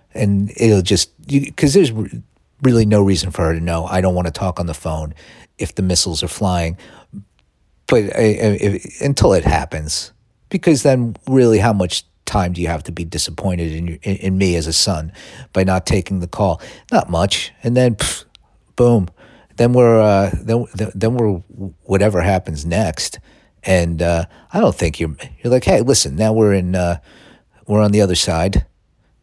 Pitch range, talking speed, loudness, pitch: 85-110 Hz, 185 wpm, -16 LUFS, 95 Hz